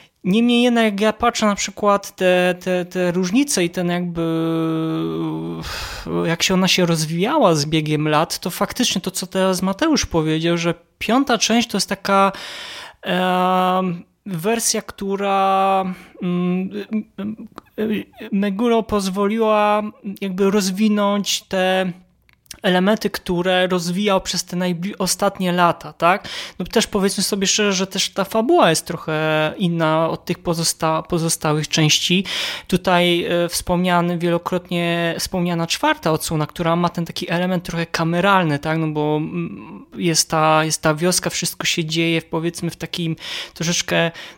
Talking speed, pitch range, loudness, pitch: 130 wpm, 170-200 Hz, -19 LUFS, 180 Hz